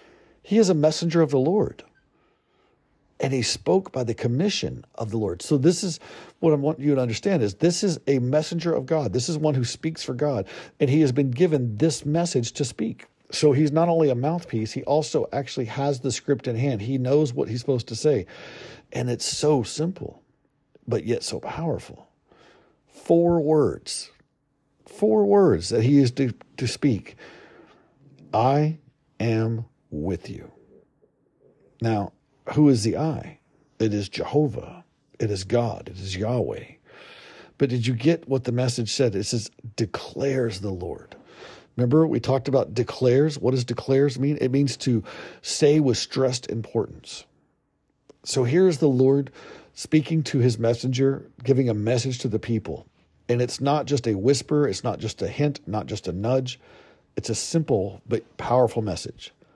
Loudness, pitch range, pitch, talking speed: -24 LUFS, 120-150 Hz, 135 Hz, 170 wpm